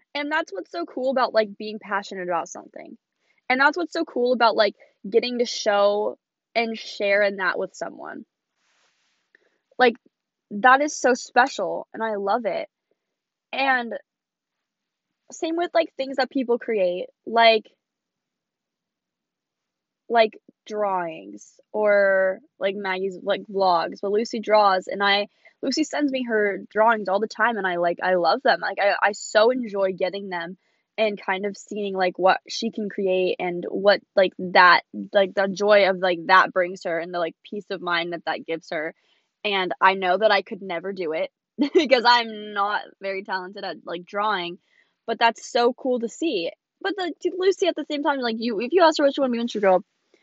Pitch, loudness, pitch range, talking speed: 210 Hz, -22 LUFS, 190-255 Hz, 175 wpm